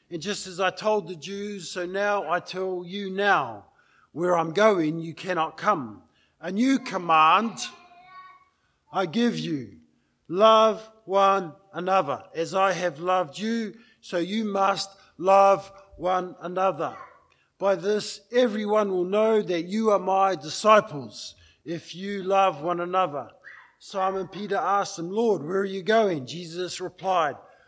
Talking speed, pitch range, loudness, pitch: 140 wpm, 175-205 Hz, -25 LUFS, 190 Hz